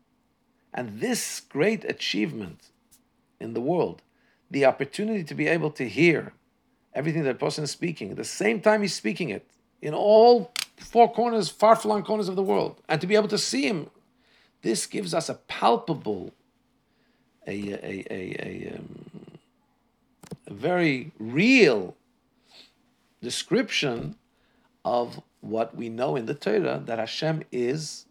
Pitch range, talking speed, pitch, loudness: 140-215 Hz, 140 wpm, 175 Hz, -25 LUFS